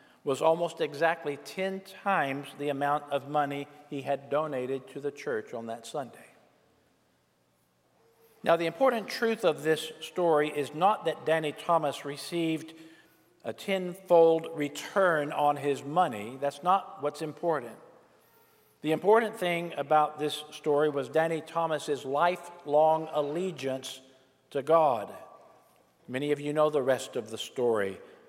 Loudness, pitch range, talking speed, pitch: -29 LUFS, 140-170 Hz, 135 wpm, 150 Hz